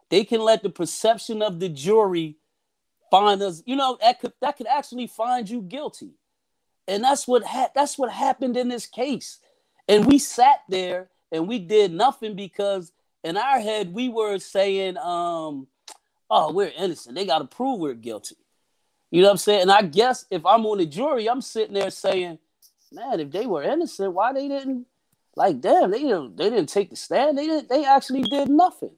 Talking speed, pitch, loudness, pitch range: 195 wpm, 230 Hz, -22 LUFS, 195-275 Hz